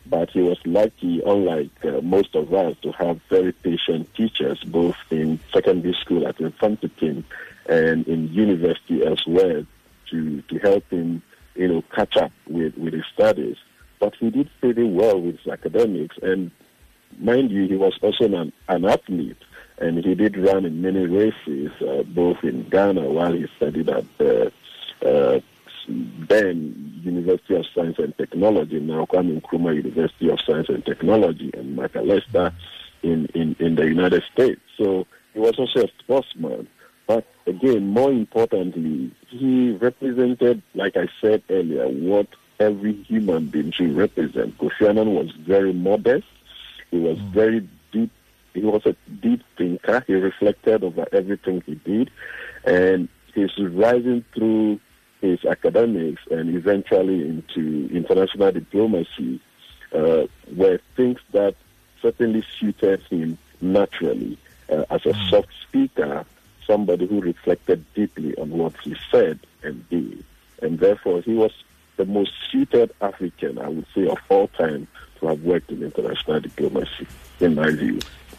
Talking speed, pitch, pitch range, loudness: 145 wpm, 100 Hz, 90-120 Hz, -21 LUFS